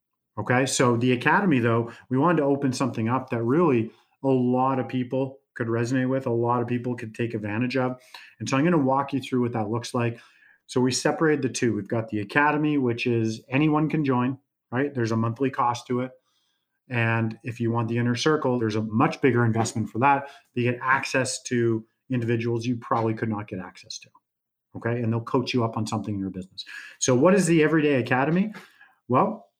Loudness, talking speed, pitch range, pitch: -24 LUFS, 215 wpm, 115-135 Hz, 125 Hz